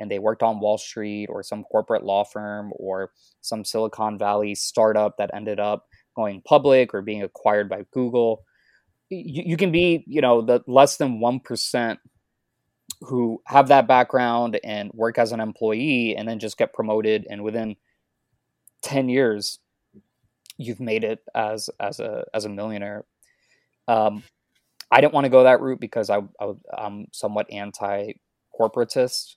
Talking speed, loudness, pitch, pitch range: 155 wpm, -22 LUFS, 110 Hz, 105-125 Hz